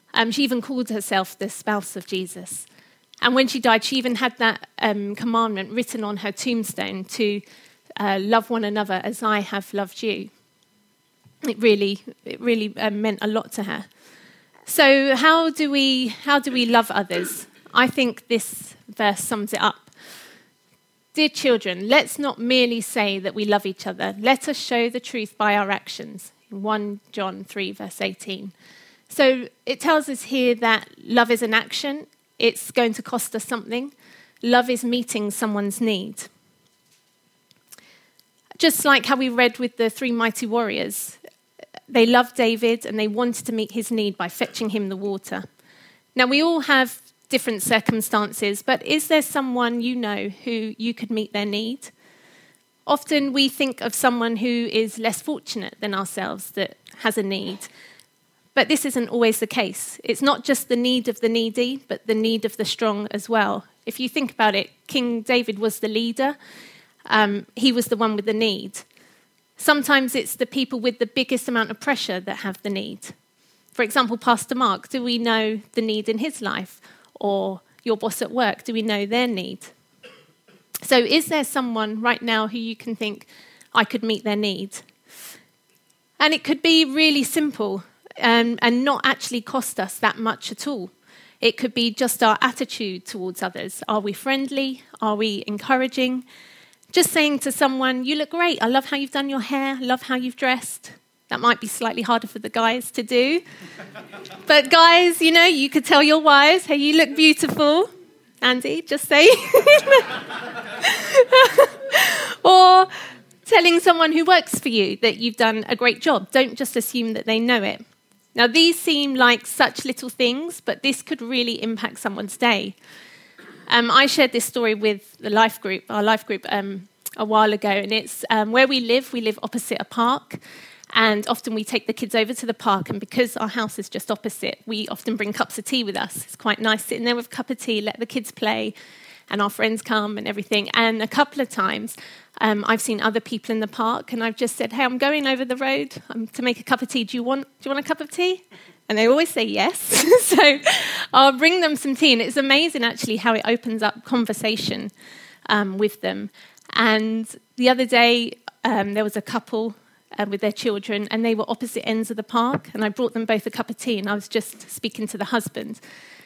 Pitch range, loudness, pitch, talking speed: 215-265 Hz, -20 LUFS, 235 Hz, 195 wpm